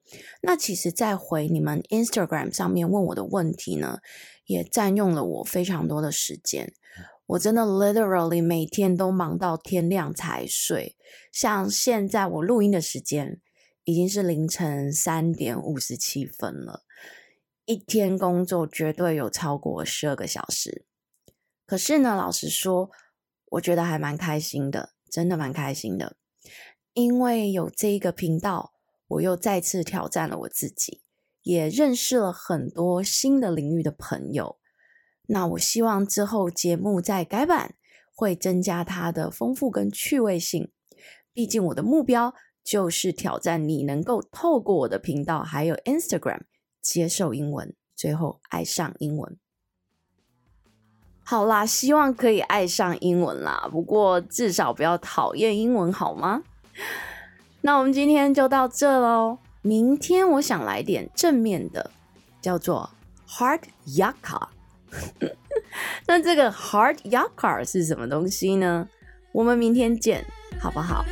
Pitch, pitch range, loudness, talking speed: 185 Hz, 165-230 Hz, -24 LUFS, 240 characters per minute